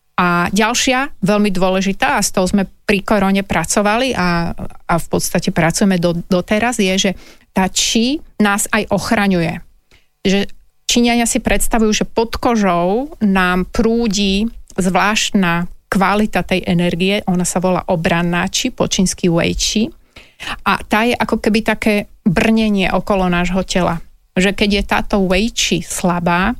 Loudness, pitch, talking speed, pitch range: -15 LUFS, 200 Hz, 145 wpm, 185-220 Hz